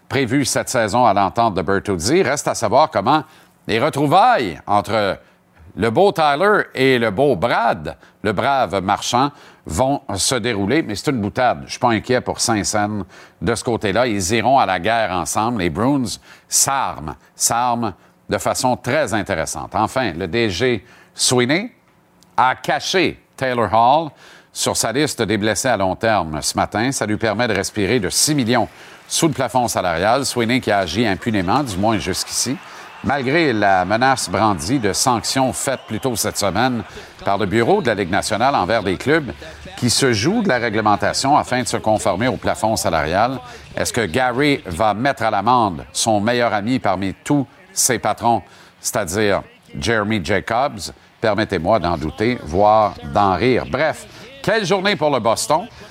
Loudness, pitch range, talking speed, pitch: -18 LUFS, 100-125 Hz, 165 wpm, 115 Hz